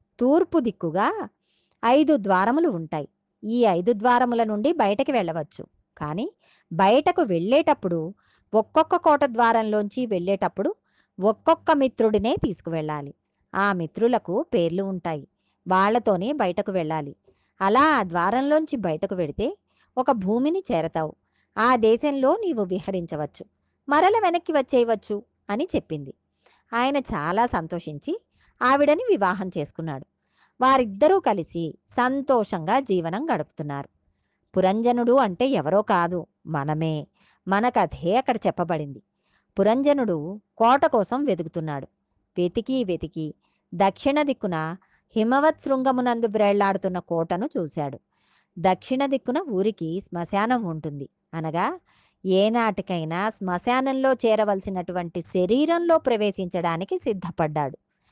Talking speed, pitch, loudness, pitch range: 90 wpm, 205 Hz, -23 LUFS, 170-255 Hz